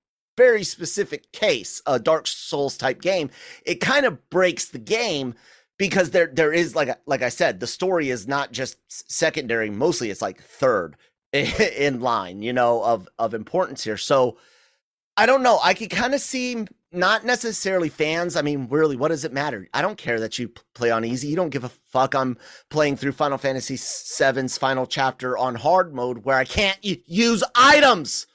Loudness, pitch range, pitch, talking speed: -22 LUFS, 130-185 Hz, 145 Hz, 190 wpm